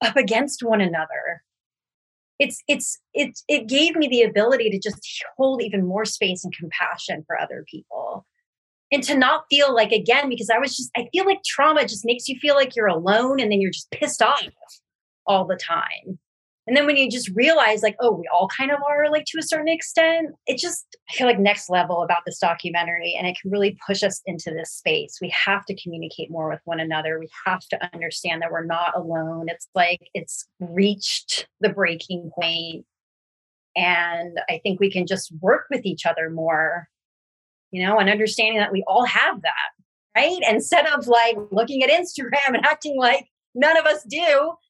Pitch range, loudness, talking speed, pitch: 175-280 Hz, -21 LUFS, 195 wpm, 215 Hz